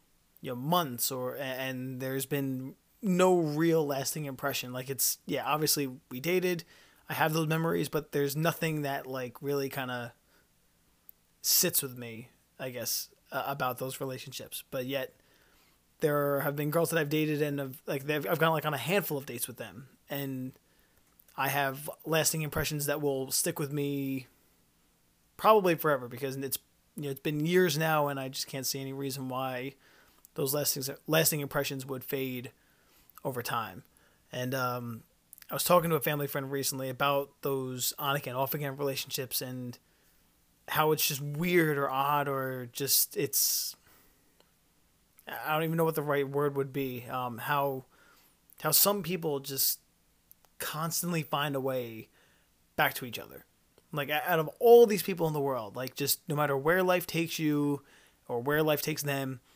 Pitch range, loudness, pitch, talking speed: 130-155 Hz, -30 LUFS, 140 Hz, 170 wpm